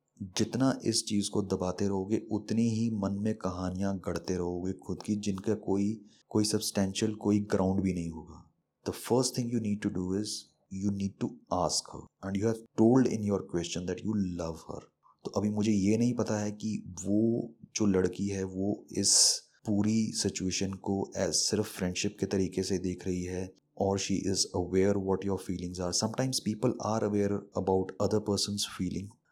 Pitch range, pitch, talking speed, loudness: 95-105 Hz, 100 Hz, 185 wpm, -31 LUFS